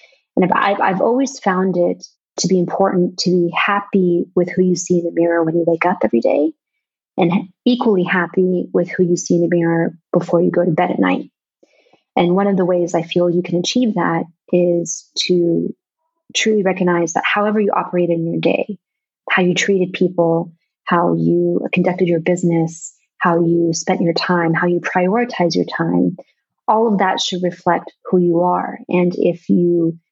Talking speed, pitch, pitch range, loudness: 190 wpm, 180 Hz, 170-190 Hz, -17 LUFS